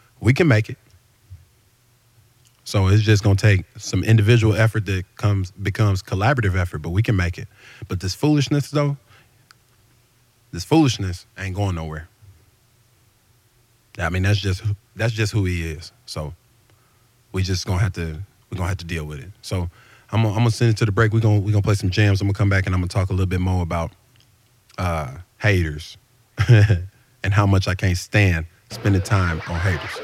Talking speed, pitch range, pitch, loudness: 190 wpm, 95-115 Hz, 105 Hz, -20 LUFS